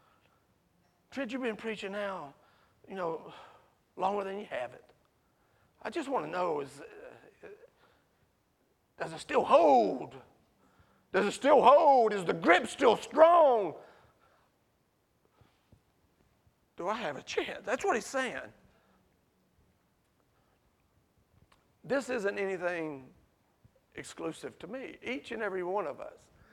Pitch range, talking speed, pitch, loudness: 195-295 Hz, 120 wpm, 225 Hz, -29 LUFS